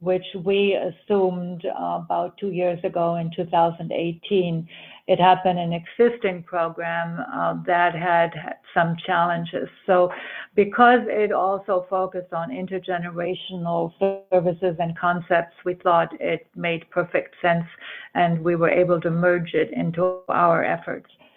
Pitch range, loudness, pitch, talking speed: 170-185 Hz, -22 LUFS, 175 Hz, 125 wpm